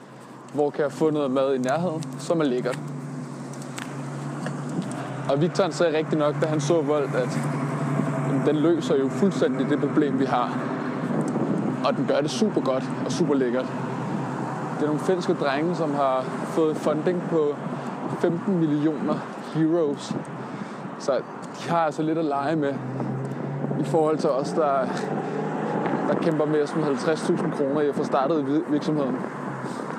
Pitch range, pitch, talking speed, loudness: 135-165 Hz, 150 Hz, 150 wpm, -25 LUFS